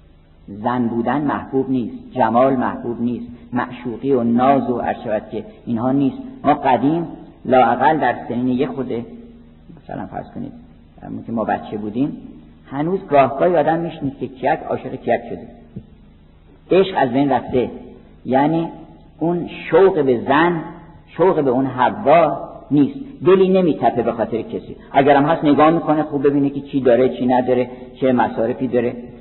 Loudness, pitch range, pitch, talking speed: -18 LUFS, 120-150 Hz, 130 Hz, 145 wpm